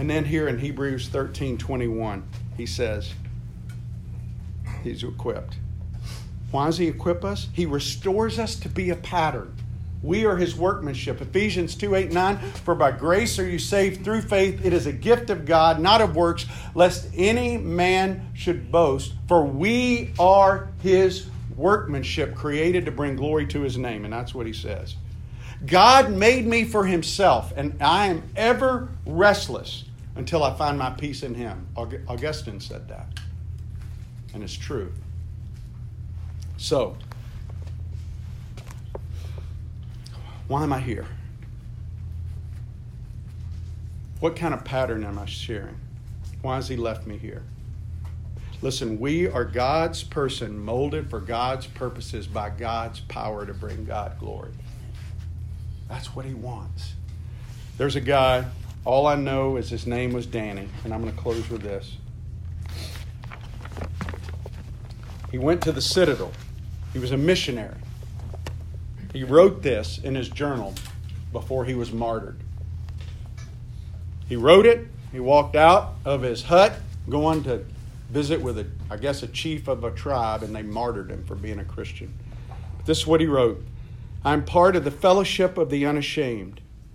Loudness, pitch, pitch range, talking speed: -23 LUFS, 115 Hz, 100-140 Hz, 145 wpm